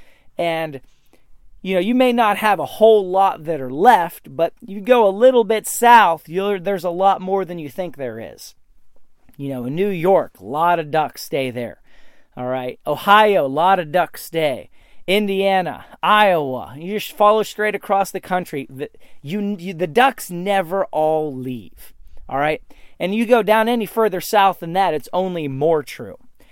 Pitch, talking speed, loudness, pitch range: 190 Hz, 180 wpm, -18 LUFS, 155-210 Hz